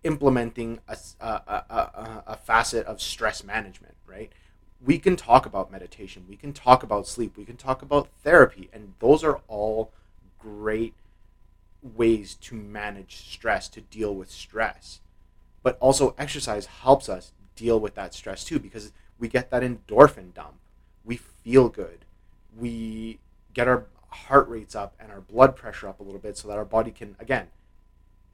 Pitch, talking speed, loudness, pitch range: 110 Hz, 165 wpm, -24 LUFS, 95-120 Hz